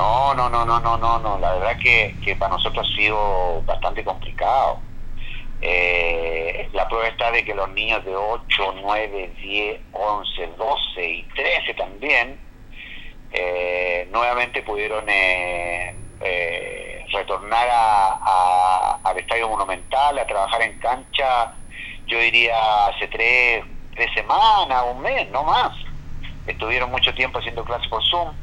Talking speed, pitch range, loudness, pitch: 135 wpm, 90-120 Hz, -20 LUFS, 105 Hz